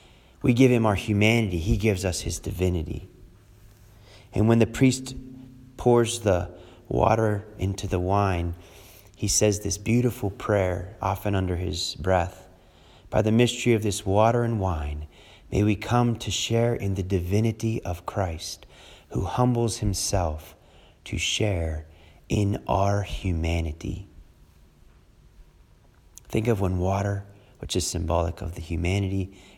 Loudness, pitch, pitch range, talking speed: -25 LUFS, 100 Hz, 90-110 Hz, 130 wpm